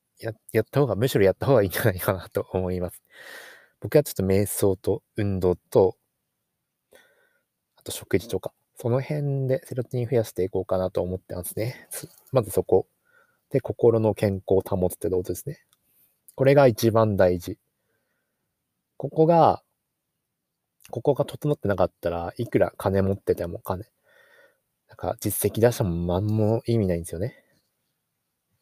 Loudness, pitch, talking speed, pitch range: -24 LUFS, 110 Hz, 305 characters per minute, 95-130 Hz